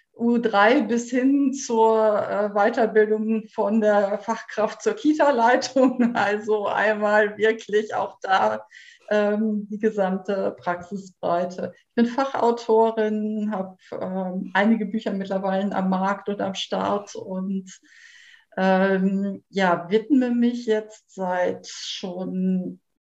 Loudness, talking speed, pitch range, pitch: -23 LUFS, 105 wpm, 195-235 Hz, 215 Hz